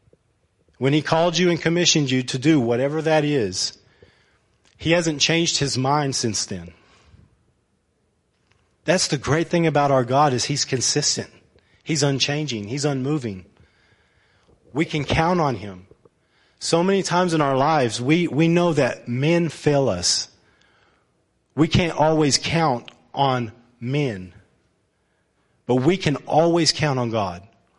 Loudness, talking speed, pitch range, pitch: -20 LUFS, 140 wpm, 115-160 Hz, 140 Hz